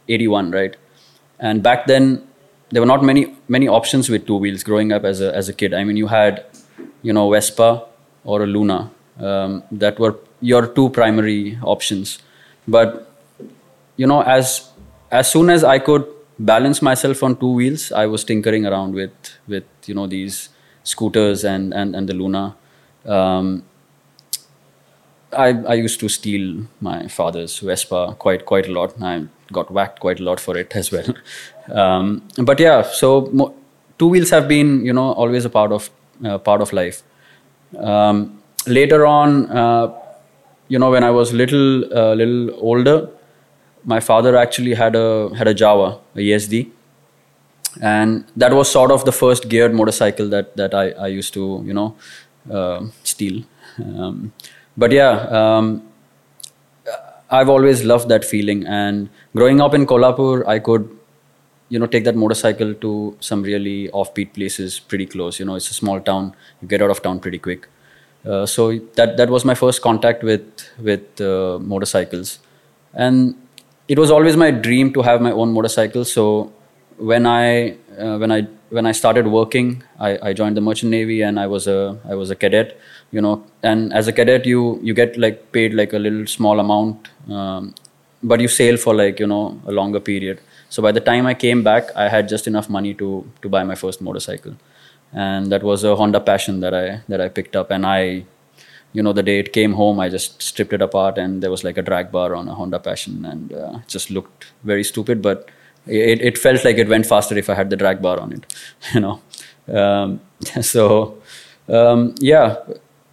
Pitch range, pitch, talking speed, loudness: 100-120 Hz, 110 Hz, 185 wpm, -16 LUFS